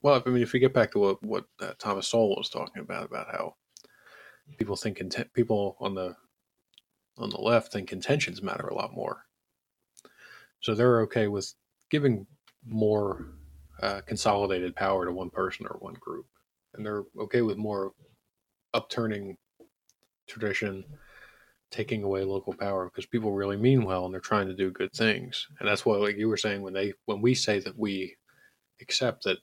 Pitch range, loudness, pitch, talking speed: 95-115 Hz, -29 LUFS, 105 Hz, 175 wpm